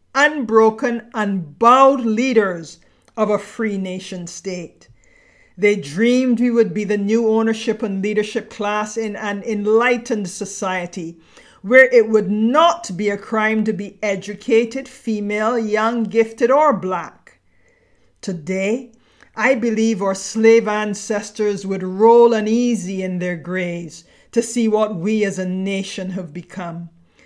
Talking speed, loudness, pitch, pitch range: 130 wpm, -18 LUFS, 215 Hz, 195-230 Hz